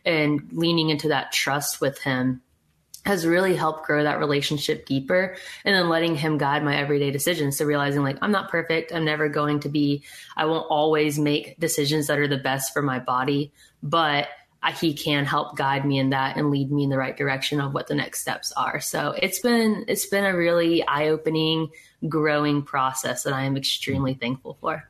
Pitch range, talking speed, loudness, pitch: 140-160 Hz, 200 wpm, -23 LUFS, 150 Hz